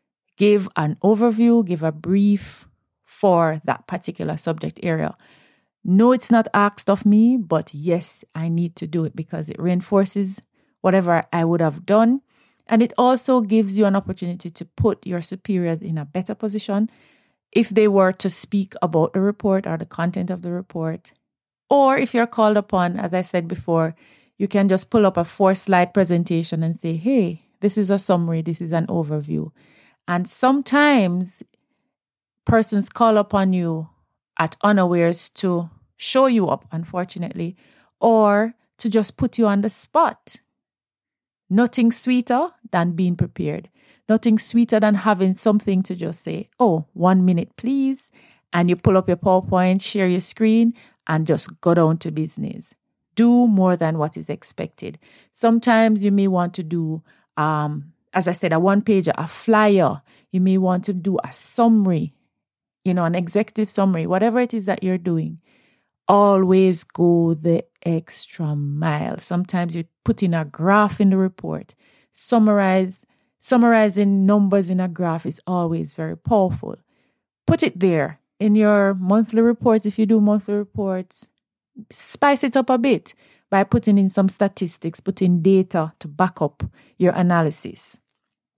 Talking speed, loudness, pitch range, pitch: 160 wpm, -19 LUFS, 170-215 Hz, 190 Hz